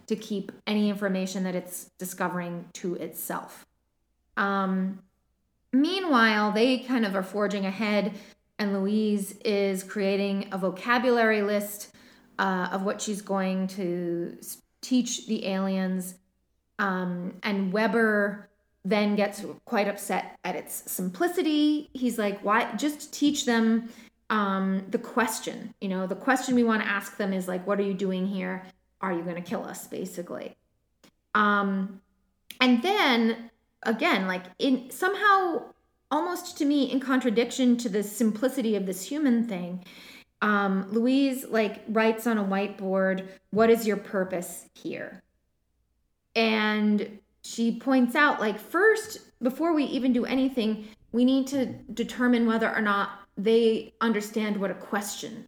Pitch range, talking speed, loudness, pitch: 195-240 Hz, 140 wpm, -27 LUFS, 210 Hz